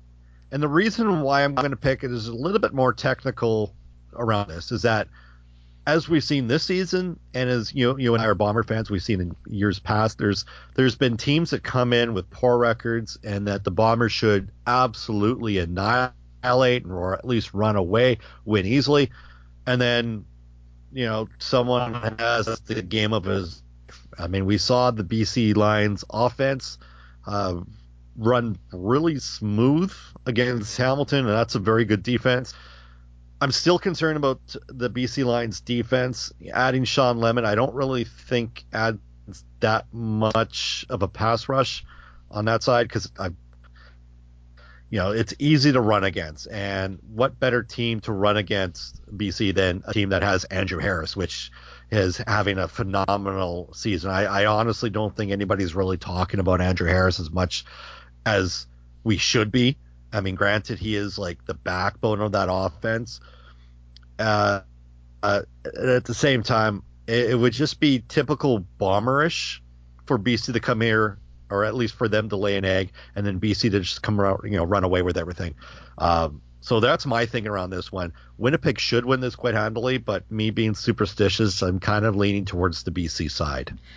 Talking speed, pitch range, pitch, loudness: 170 wpm, 90-120 Hz, 105 Hz, -23 LUFS